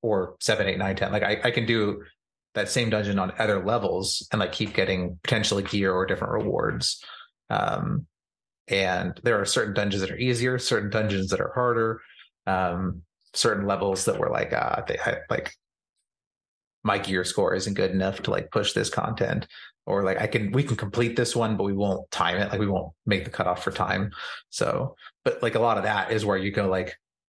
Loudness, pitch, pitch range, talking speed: -26 LUFS, 100 Hz, 95-110 Hz, 205 wpm